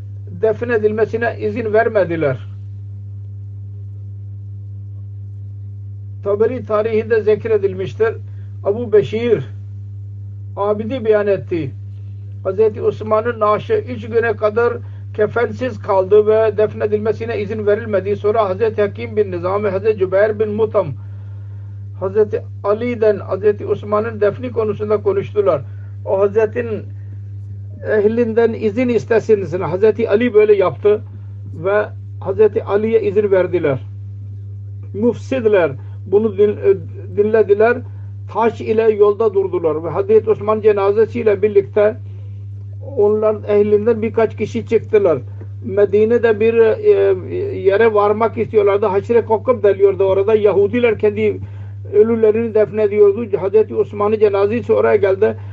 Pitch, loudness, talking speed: 205 Hz, -16 LUFS, 100 wpm